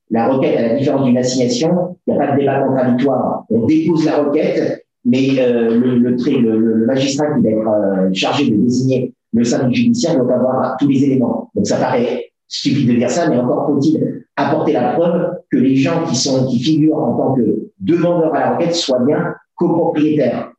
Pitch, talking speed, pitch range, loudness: 135 Hz, 205 wpm, 125-155 Hz, -15 LUFS